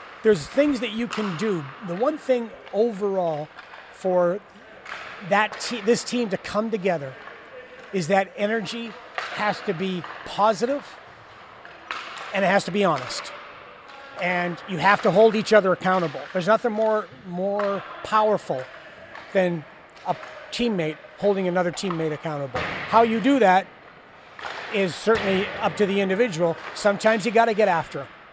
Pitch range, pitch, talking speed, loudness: 180-225 Hz, 200 Hz, 145 wpm, -23 LUFS